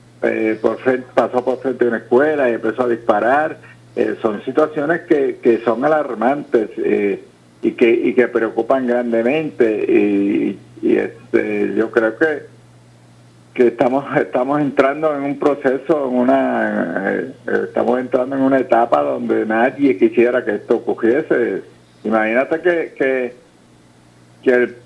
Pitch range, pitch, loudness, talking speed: 110-150 Hz, 125 Hz, -17 LUFS, 140 wpm